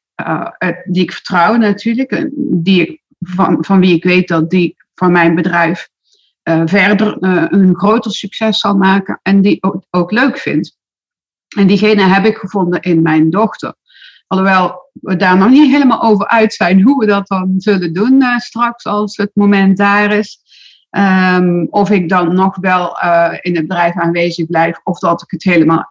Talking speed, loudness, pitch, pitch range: 180 wpm, -11 LUFS, 190 Hz, 175-215 Hz